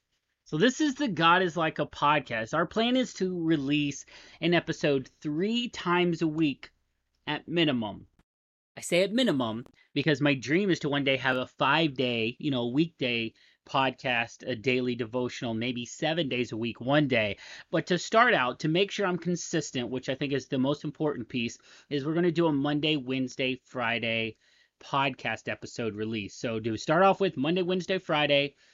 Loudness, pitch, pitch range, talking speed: -28 LUFS, 145 Hz, 125-170 Hz, 185 wpm